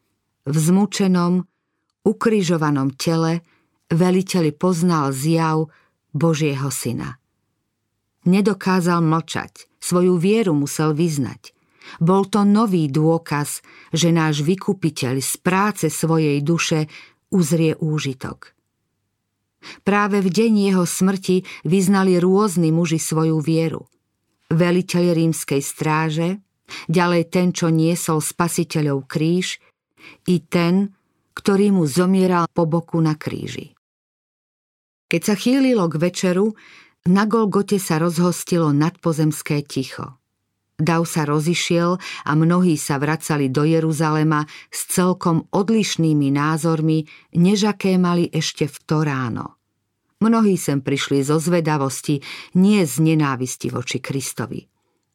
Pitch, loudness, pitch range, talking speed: 165 Hz, -19 LUFS, 150-180 Hz, 105 wpm